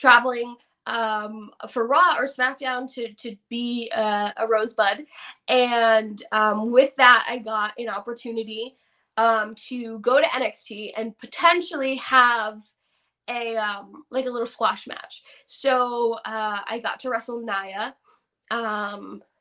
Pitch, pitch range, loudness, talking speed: 230 Hz, 215-250 Hz, -23 LUFS, 130 wpm